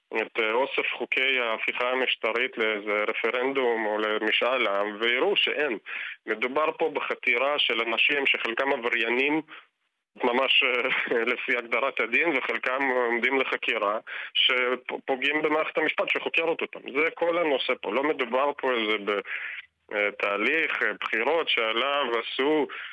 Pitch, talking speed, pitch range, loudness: 125 Hz, 115 wpm, 110-155 Hz, -25 LUFS